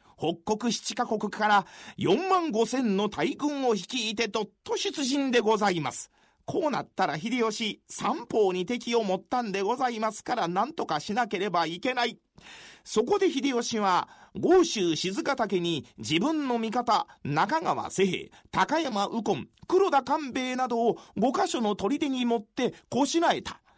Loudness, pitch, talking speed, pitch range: -27 LUFS, 230 Hz, 280 characters per minute, 205-270 Hz